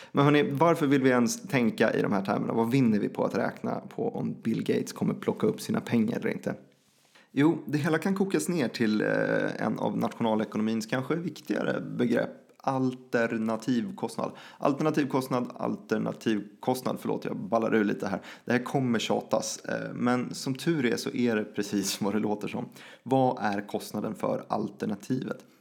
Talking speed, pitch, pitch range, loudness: 165 wpm, 125 Hz, 110-140 Hz, -29 LUFS